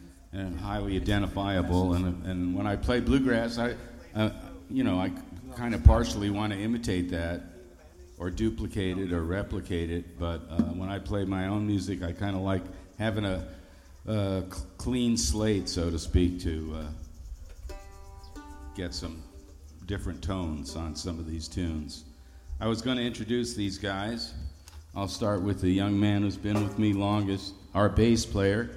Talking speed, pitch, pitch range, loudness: 165 wpm, 95 Hz, 85-105 Hz, -30 LUFS